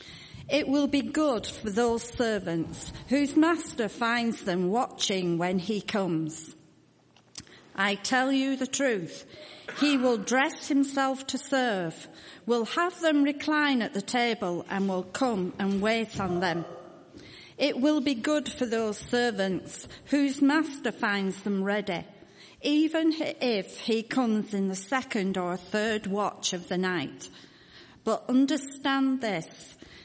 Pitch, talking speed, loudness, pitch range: 235 Hz, 135 wpm, -28 LUFS, 195-275 Hz